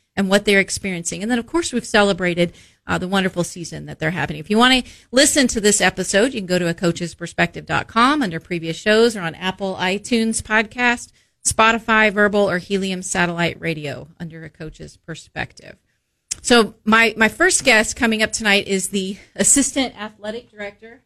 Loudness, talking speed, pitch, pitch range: -18 LUFS, 175 wpm, 205 Hz, 180-225 Hz